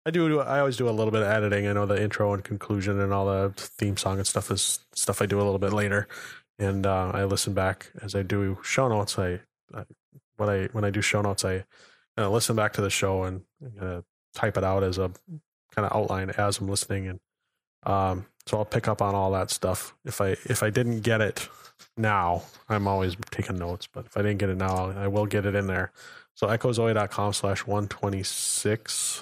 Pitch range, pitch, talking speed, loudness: 95-110 Hz, 100 Hz, 230 wpm, -27 LUFS